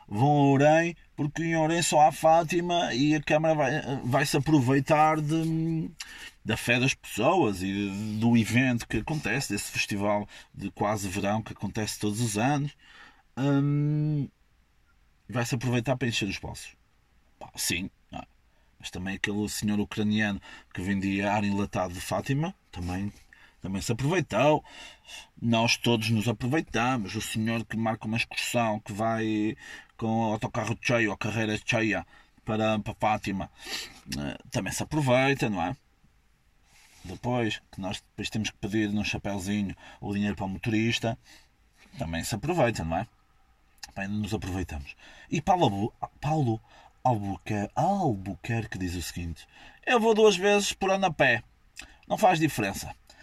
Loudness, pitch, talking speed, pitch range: -27 LUFS, 115 Hz, 145 wpm, 105-140 Hz